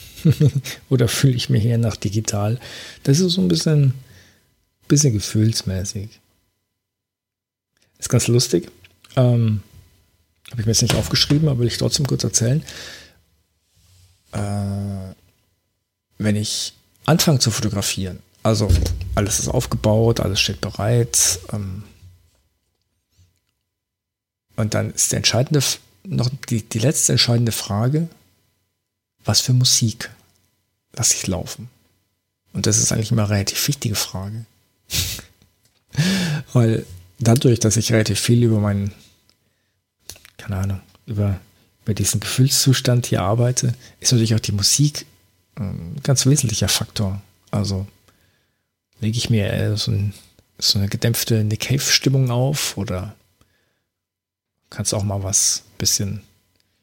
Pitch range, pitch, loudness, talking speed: 100-120 Hz, 105 Hz, -19 LUFS, 120 wpm